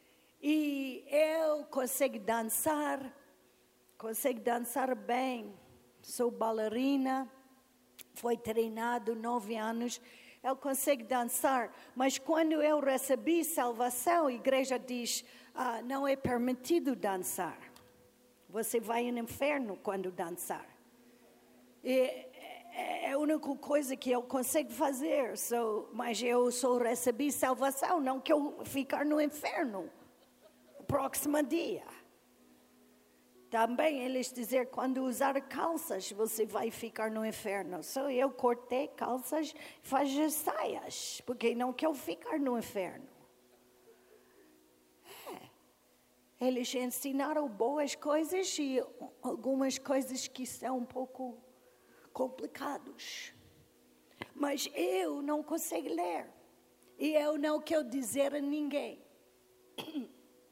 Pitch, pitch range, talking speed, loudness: 255 Hz, 230-285 Hz, 105 wpm, -34 LUFS